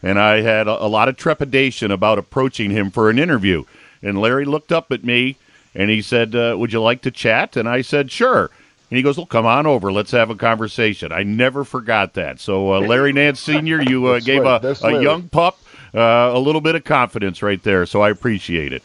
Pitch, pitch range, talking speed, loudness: 120 Hz, 105-135 Hz, 230 wpm, -16 LUFS